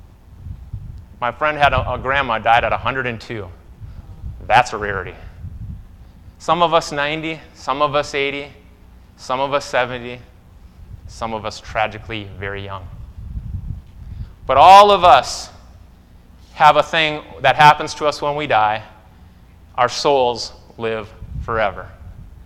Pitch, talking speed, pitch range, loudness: 110 Hz, 125 wpm, 90-135 Hz, -16 LUFS